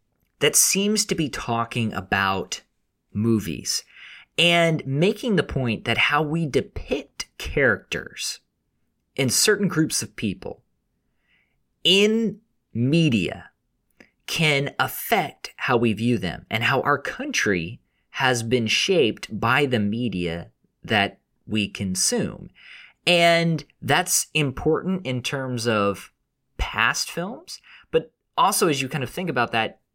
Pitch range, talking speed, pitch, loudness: 115-165 Hz, 120 wpm, 130 Hz, -22 LUFS